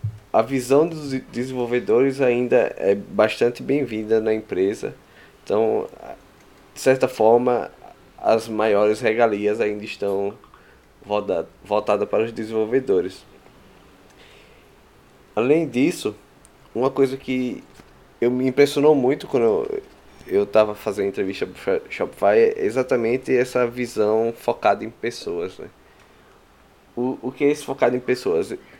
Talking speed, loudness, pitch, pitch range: 115 wpm, -21 LUFS, 125 Hz, 110-135 Hz